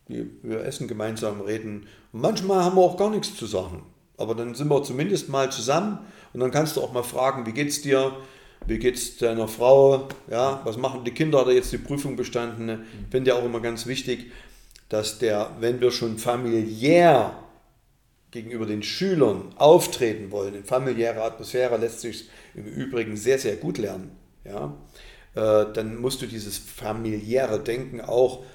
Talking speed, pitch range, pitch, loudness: 170 wpm, 110-135 Hz, 120 Hz, -24 LUFS